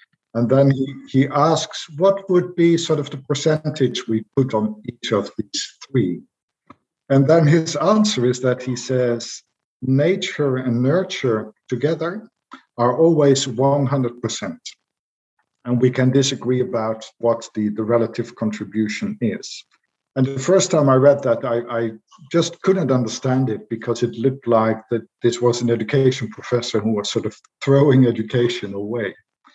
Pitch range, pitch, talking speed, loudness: 120-150 Hz, 130 Hz, 150 wpm, -19 LUFS